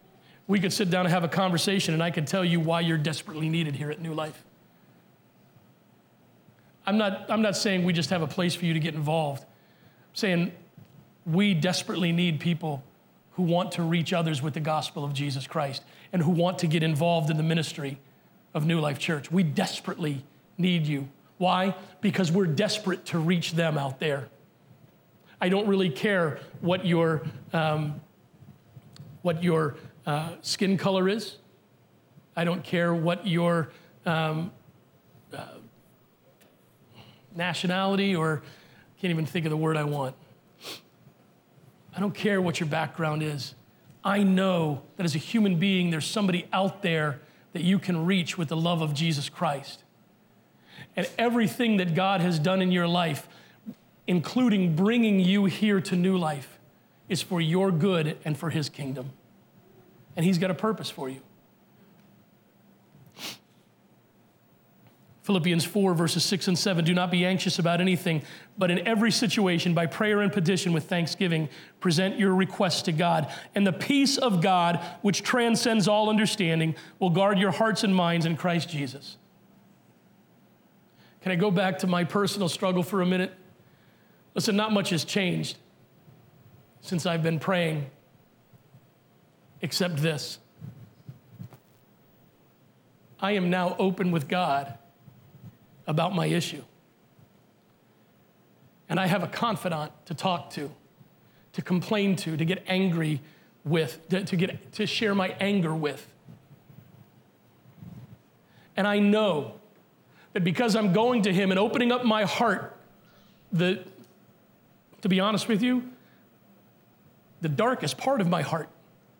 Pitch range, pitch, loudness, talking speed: 160-190 Hz, 175 Hz, -26 LUFS, 145 wpm